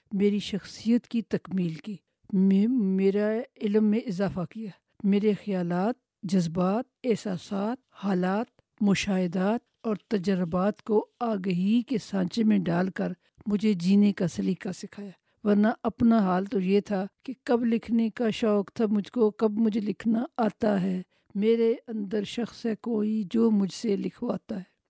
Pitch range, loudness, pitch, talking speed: 195-225 Hz, -27 LUFS, 210 Hz, 145 wpm